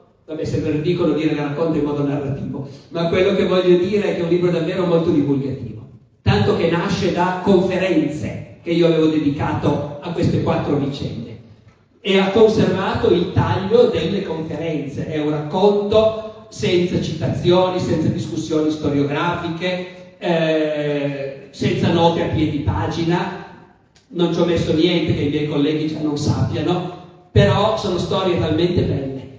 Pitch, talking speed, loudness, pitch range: 165 Hz, 150 wpm, -19 LUFS, 145-180 Hz